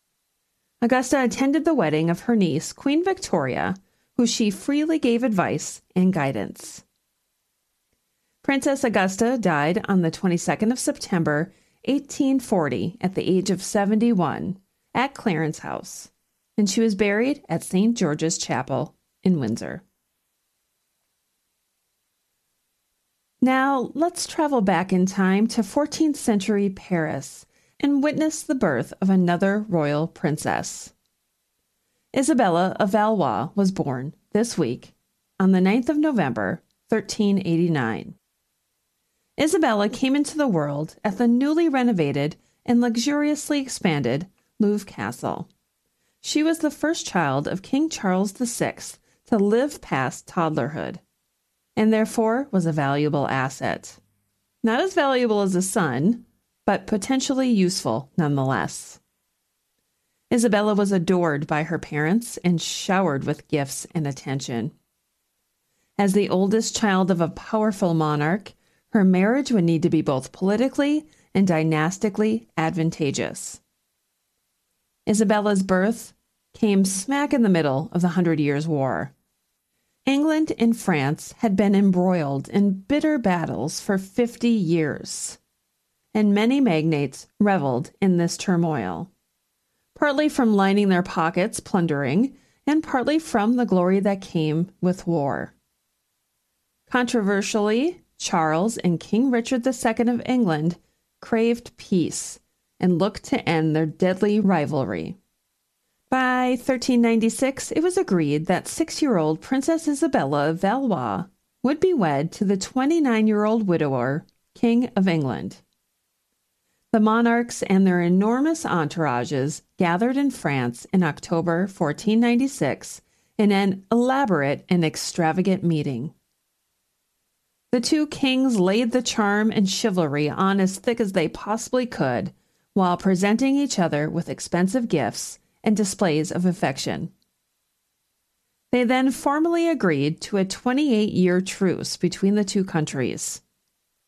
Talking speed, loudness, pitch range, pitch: 125 wpm, -22 LUFS, 165-245 Hz, 200 Hz